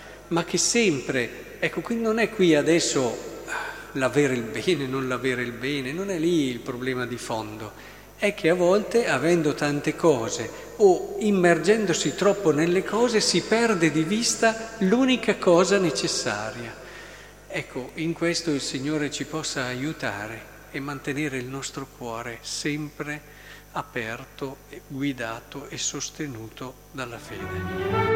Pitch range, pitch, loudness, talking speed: 135-185 Hz, 155 Hz, -24 LUFS, 135 wpm